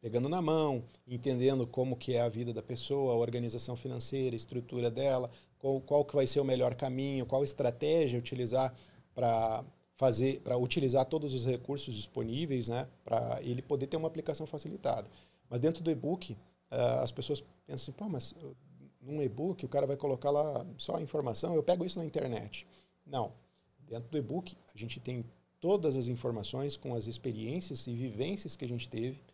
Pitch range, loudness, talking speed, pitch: 120-145 Hz, -35 LUFS, 185 wpm, 130 Hz